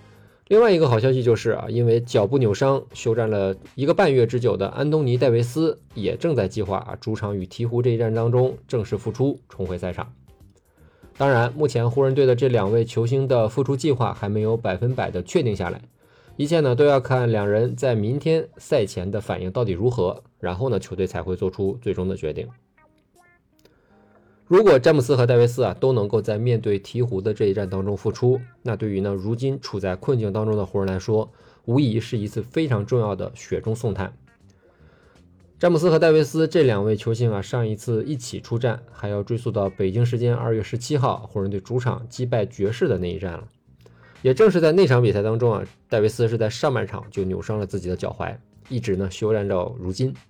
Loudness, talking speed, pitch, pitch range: -22 LUFS, 310 characters per minute, 115 Hz, 100-125 Hz